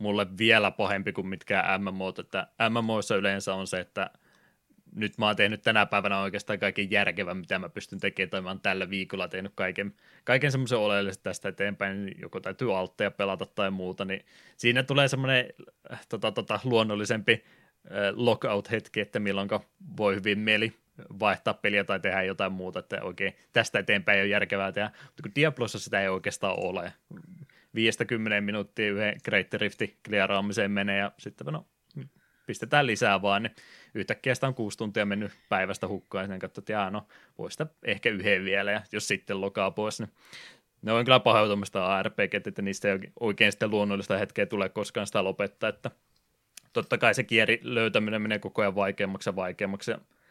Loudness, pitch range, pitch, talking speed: -28 LUFS, 100-110 Hz, 105 Hz, 165 wpm